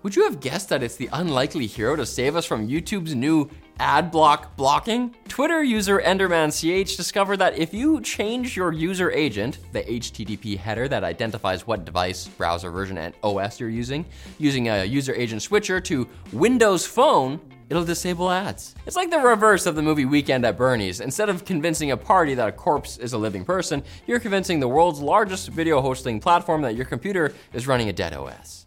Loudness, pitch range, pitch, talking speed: -22 LUFS, 115-190 Hz, 155 Hz, 190 wpm